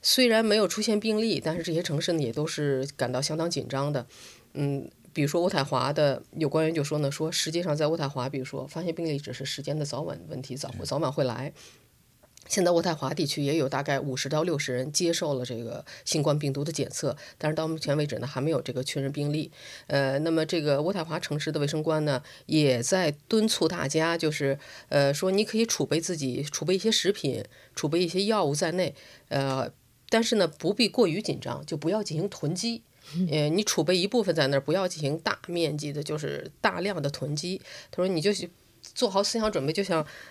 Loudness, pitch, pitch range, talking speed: -28 LUFS, 155 Hz, 140-180 Hz, 320 characters per minute